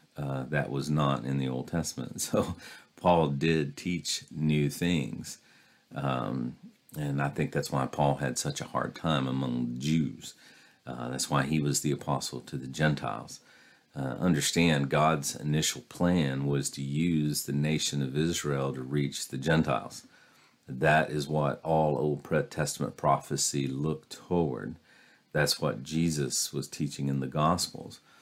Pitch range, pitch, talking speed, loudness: 70-80 Hz, 75 Hz, 150 wpm, -30 LUFS